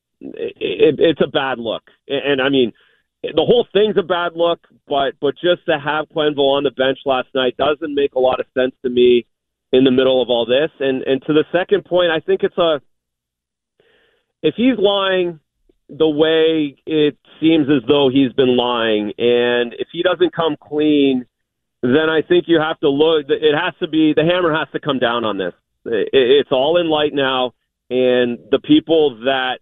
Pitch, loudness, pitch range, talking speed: 150 Hz, -16 LUFS, 130-175 Hz, 200 wpm